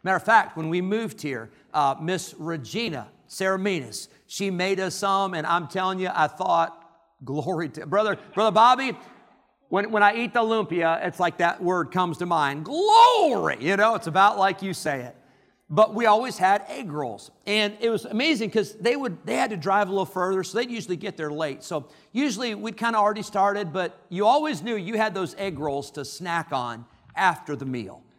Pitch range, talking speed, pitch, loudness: 165-210 Hz, 205 wpm, 190 Hz, -24 LUFS